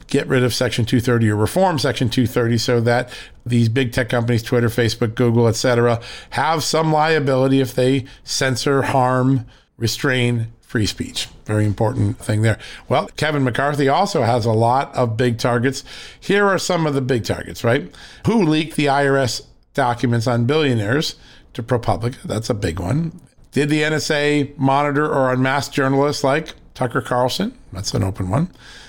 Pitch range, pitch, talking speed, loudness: 120-140 Hz, 130 Hz, 160 wpm, -19 LUFS